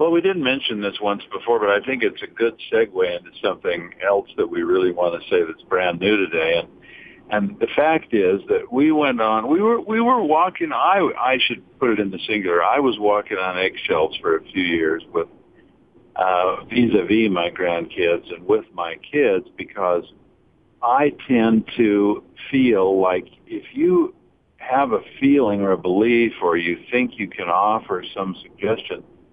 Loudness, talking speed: -20 LUFS, 185 wpm